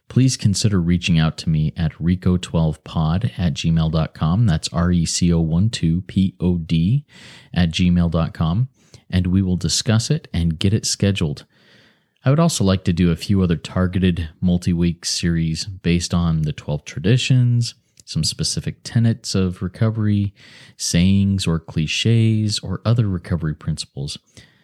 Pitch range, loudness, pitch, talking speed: 85-105 Hz, -19 LUFS, 90 Hz, 150 wpm